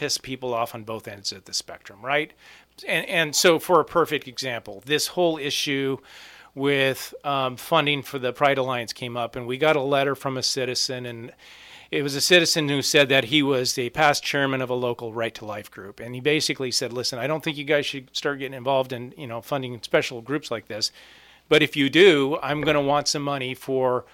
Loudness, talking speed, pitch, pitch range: -23 LUFS, 225 wpm, 135 Hz, 125-145 Hz